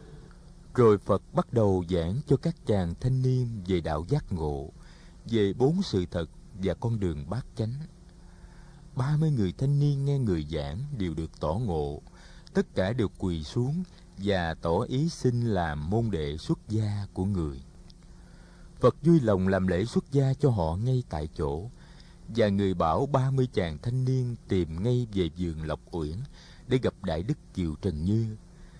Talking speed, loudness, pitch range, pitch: 175 wpm, -28 LUFS, 90-140 Hz, 110 Hz